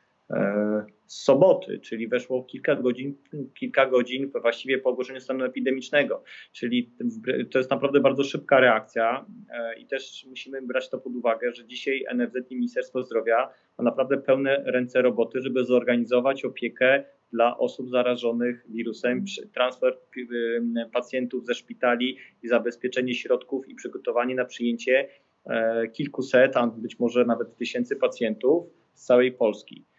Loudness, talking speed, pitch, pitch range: -25 LUFS, 130 wpm, 125 Hz, 120-135 Hz